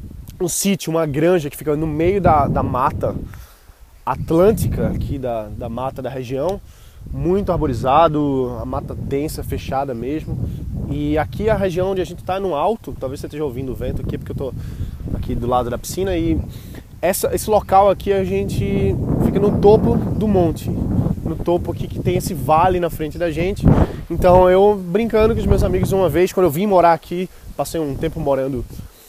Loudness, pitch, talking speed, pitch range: -18 LUFS, 155 Hz, 190 wpm, 125-180 Hz